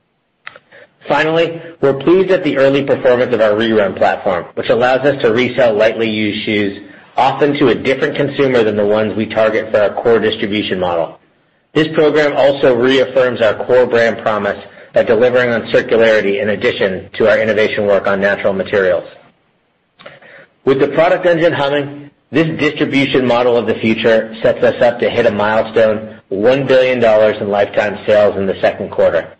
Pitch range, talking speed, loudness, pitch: 110-145 Hz, 165 wpm, -13 LUFS, 125 Hz